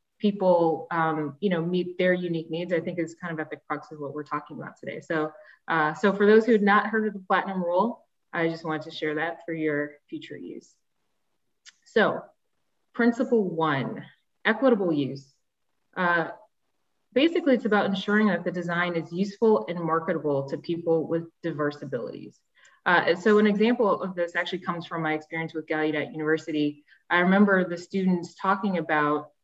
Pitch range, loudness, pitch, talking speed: 155-195 Hz, -26 LUFS, 170 Hz, 175 wpm